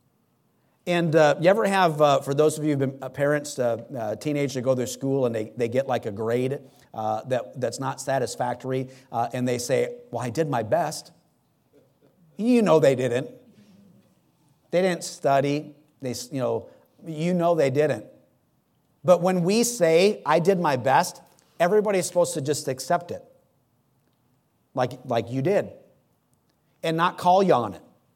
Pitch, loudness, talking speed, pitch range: 145 Hz, -24 LUFS, 170 wpm, 125-175 Hz